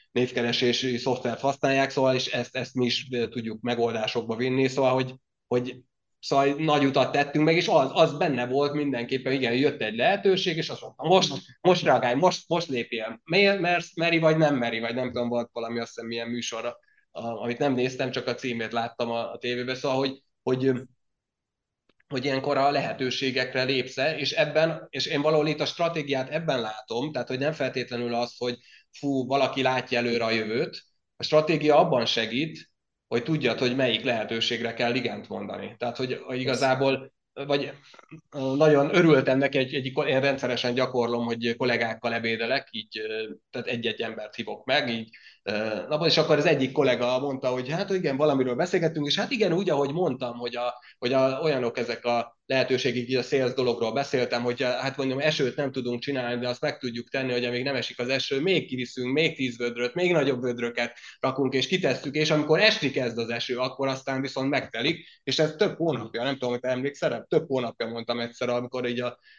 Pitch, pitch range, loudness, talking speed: 130 Hz, 120-145 Hz, -26 LUFS, 185 wpm